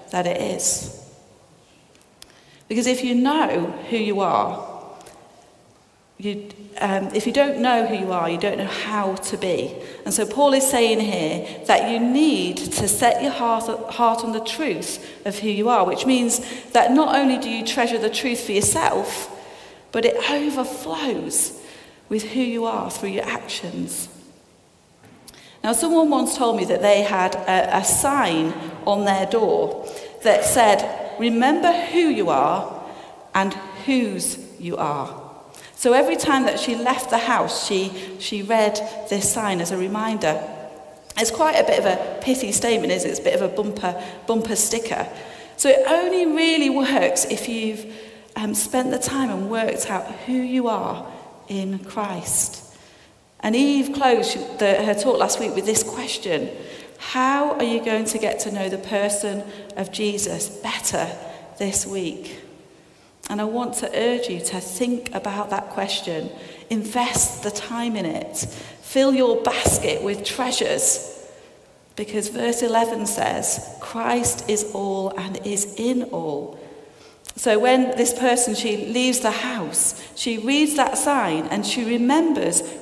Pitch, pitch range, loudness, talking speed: 230 Hz, 205-260 Hz, -21 LUFS, 160 wpm